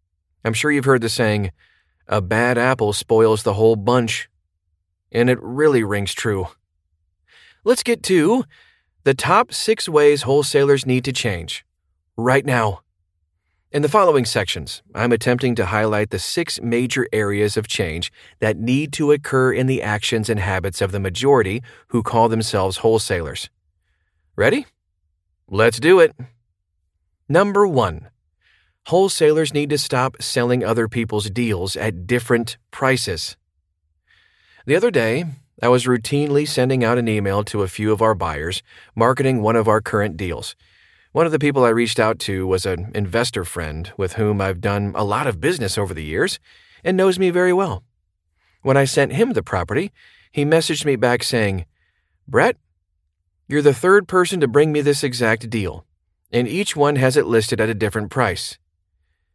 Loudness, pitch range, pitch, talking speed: -19 LUFS, 95-130 Hz, 115 Hz, 160 wpm